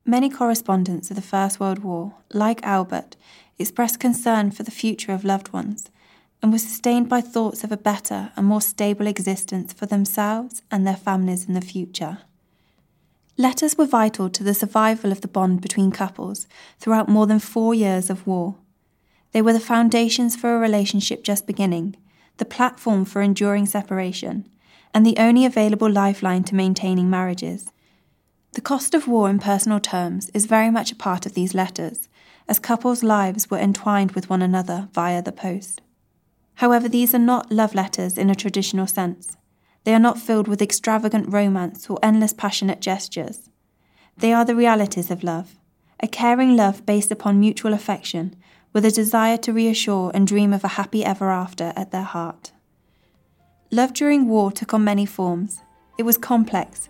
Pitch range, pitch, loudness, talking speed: 190-225 Hz, 205 Hz, -20 LUFS, 170 wpm